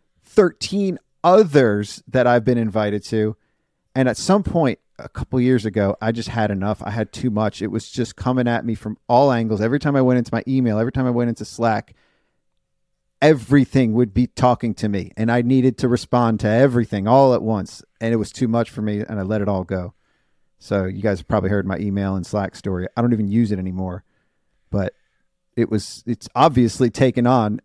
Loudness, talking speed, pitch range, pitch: -19 LUFS, 215 wpm, 105-125 Hz, 115 Hz